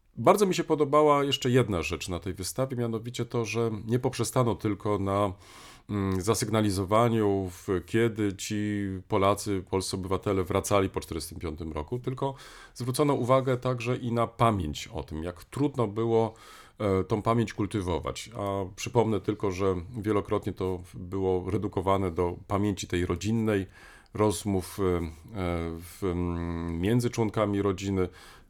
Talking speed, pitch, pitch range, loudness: 120 wpm, 105 Hz, 95-115 Hz, -28 LUFS